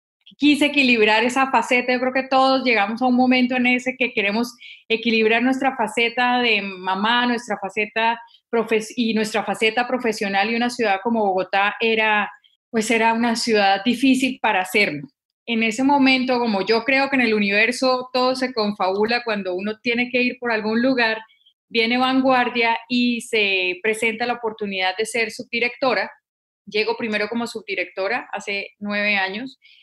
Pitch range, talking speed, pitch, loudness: 210-250 Hz, 160 wpm, 230 Hz, -20 LUFS